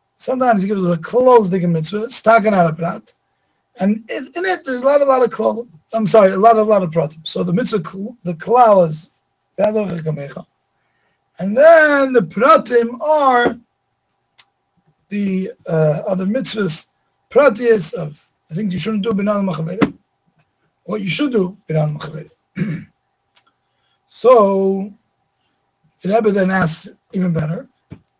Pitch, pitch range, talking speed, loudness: 205 Hz, 175-240 Hz, 135 wpm, -16 LUFS